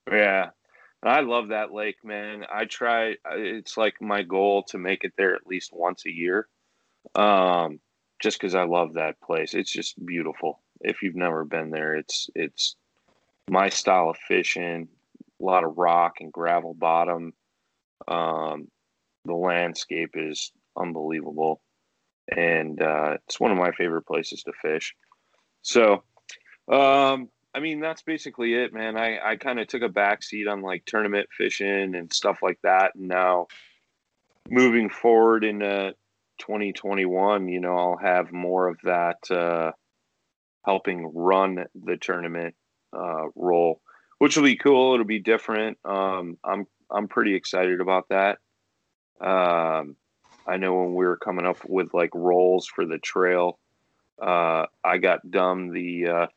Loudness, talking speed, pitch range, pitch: -24 LUFS, 150 wpm, 85-105 Hz, 90 Hz